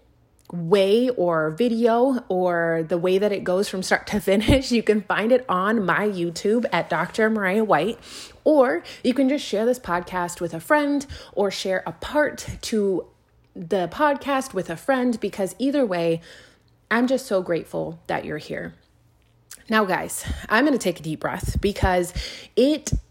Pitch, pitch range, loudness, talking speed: 200 Hz, 175-240 Hz, -22 LUFS, 170 wpm